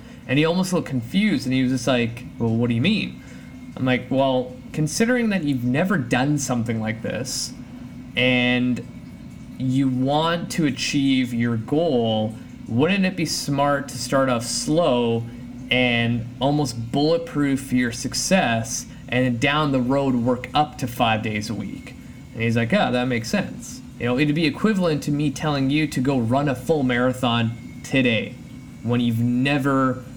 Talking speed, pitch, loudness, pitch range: 165 wpm, 130 Hz, -22 LUFS, 120-145 Hz